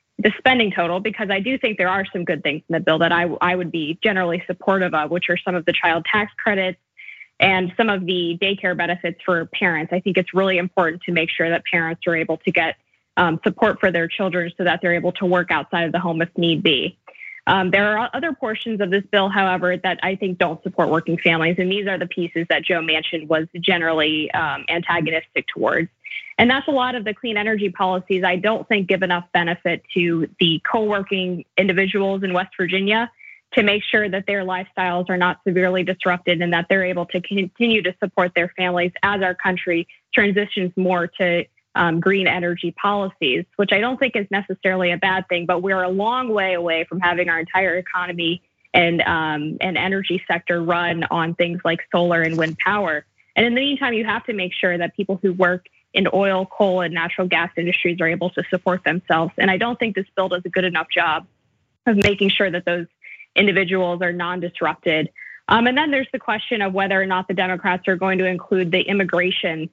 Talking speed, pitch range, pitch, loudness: 215 wpm, 175-195 Hz, 185 Hz, -20 LUFS